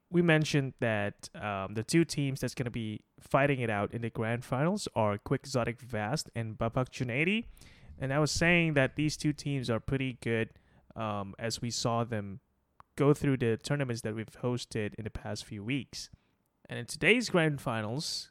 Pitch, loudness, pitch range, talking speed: 125 Hz, -31 LUFS, 110-145 Hz, 190 wpm